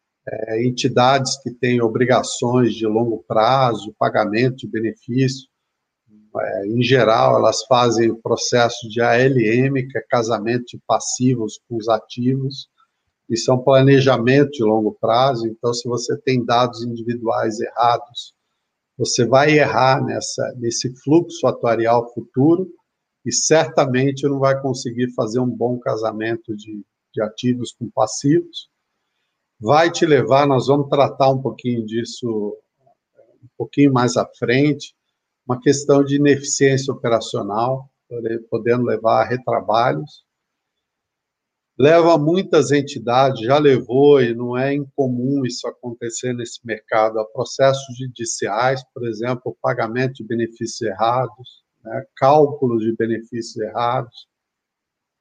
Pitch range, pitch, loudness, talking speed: 115-135 Hz, 125 Hz, -18 LUFS, 125 wpm